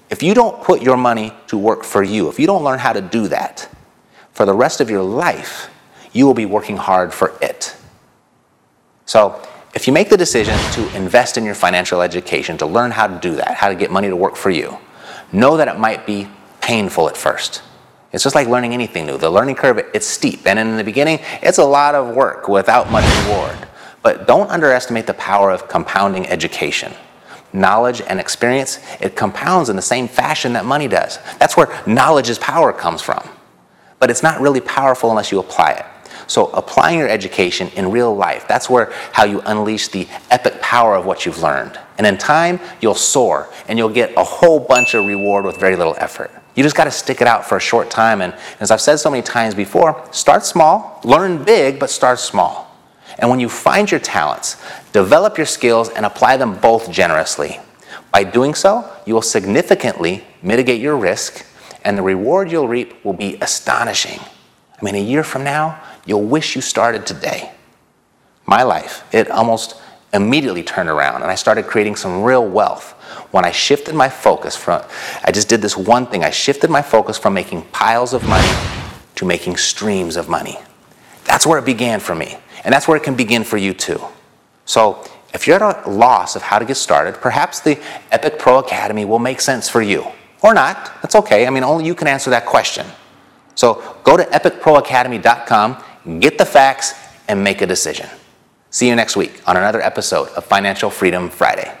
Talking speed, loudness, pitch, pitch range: 200 wpm, -14 LUFS, 120 Hz, 105-140 Hz